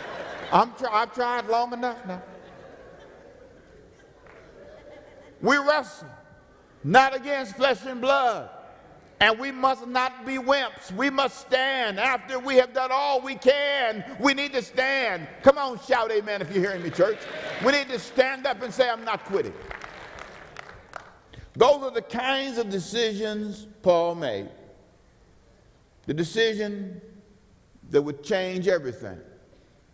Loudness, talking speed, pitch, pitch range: -24 LUFS, 135 wpm, 250 Hz, 205-270 Hz